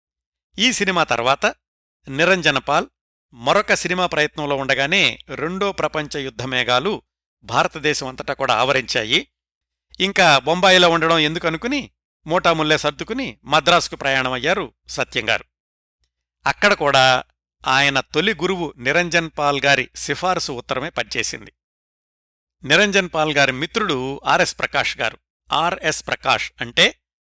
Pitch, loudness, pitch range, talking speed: 145 Hz, -18 LUFS, 110-170 Hz, 95 wpm